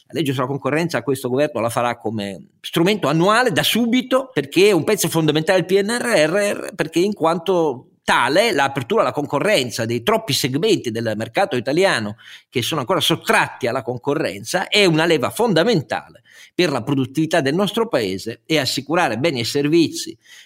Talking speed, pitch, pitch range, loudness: 160 wpm, 155 Hz, 130-195 Hz, -18 LUFS